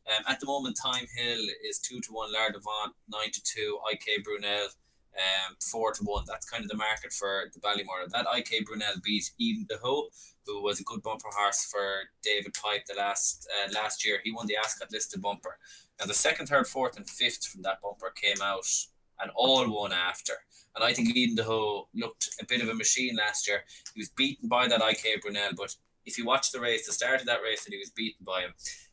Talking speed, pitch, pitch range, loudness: 225 wpm, 110 Hz, 100-130 Hz, -29 LUFS